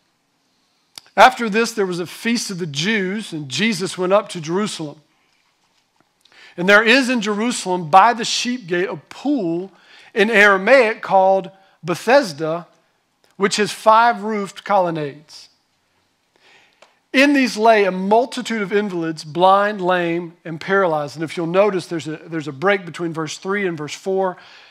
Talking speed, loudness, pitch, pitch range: 150 wpm, -17 LUFS, 190 Hz, 170-215 Hz